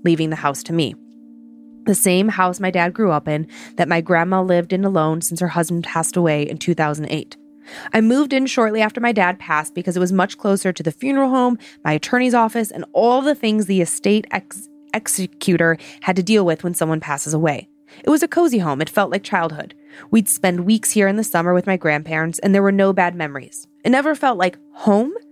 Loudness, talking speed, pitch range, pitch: -18 LUFS, 220 wpm, 165-225 Hz, 185 Hz